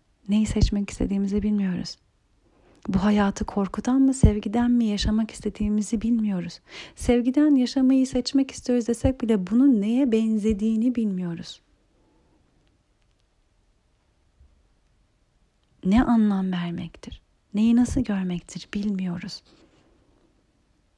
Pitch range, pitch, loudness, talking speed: 200-240 Hz, 215 Hz, -23 LUFS, 85 wpm